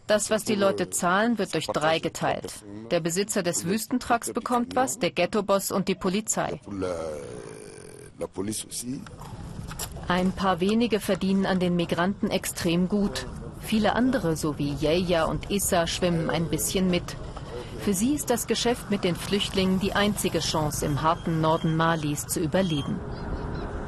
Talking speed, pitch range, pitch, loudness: 145 wpm, 165-205 Hz, 185 Hz, -26 LUFS